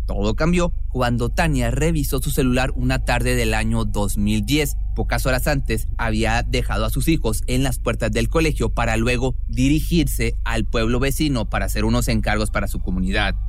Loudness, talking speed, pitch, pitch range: -21 LUFS, 170 wpm, 120 Hz, 110-130 Hz